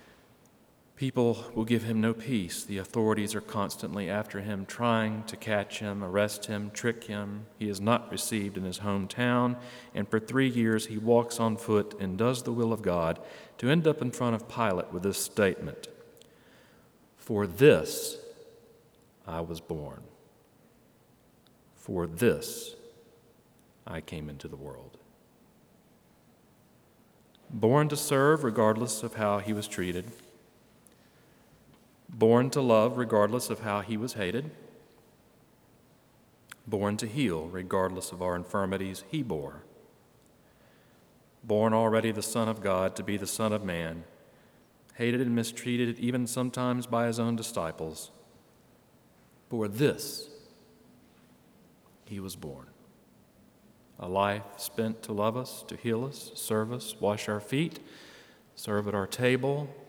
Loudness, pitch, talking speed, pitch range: -30 LUFS, 110 Hz, 135 wpm, 100-120 Hz